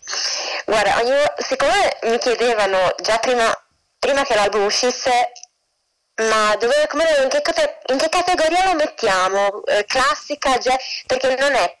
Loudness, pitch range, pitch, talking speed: -18 LUFS, 220-300 Hz, 260 Hz, 140 wpm